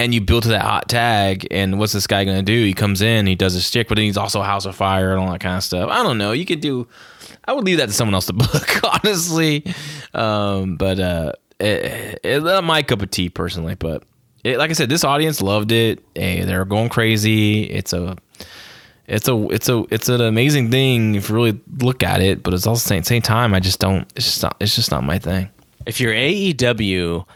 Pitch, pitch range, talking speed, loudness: 110 Hz, 95-120 Hz, 240 wpm, -18 LUFS